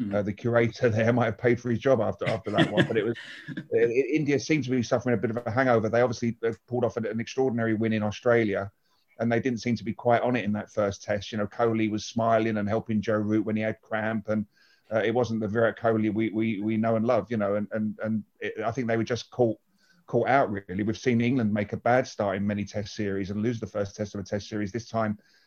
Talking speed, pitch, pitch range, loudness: 270 wpm, 110 Hz, 105-120 Hz, -27 LUFS